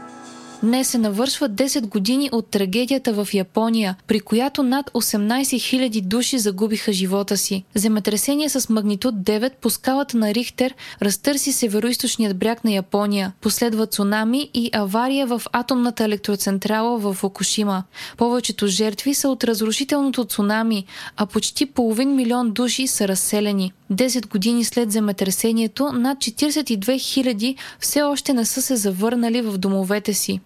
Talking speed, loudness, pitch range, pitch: 135 wpm, -20 LUFS, 205-255 Hz, 225 Hz